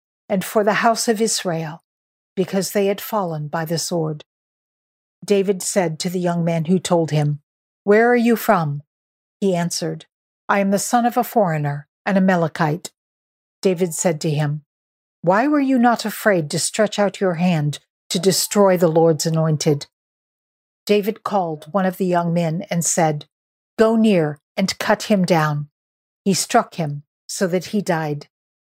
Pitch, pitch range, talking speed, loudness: 180 Hz, 160-205 Hz, 165 wpm, -19 LUFS